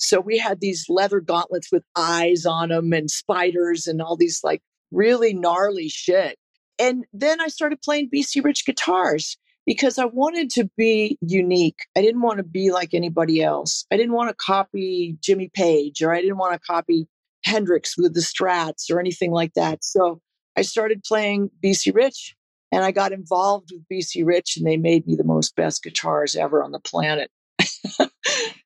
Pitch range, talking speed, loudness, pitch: 170-225 Hz, 180 wpm, -21 LUFS, 185 Hz